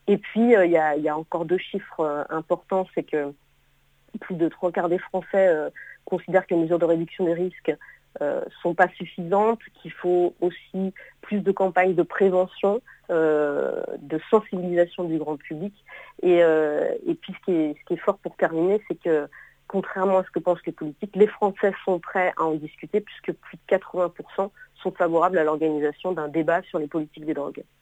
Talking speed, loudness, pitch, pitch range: 200 wpm, -24 LUFS, 180 Hz, 165-195 Hz